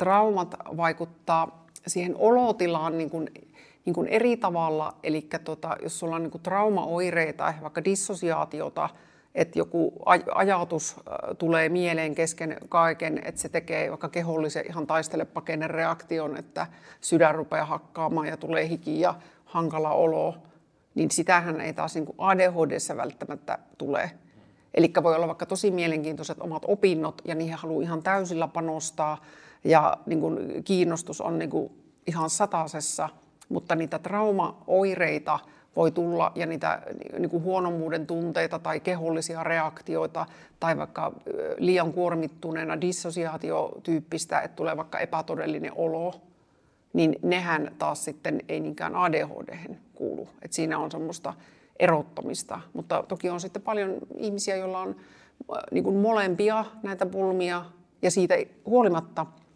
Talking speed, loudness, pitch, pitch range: 125 wpm, -27 LUFS, 165 Hz, 160-180 Hz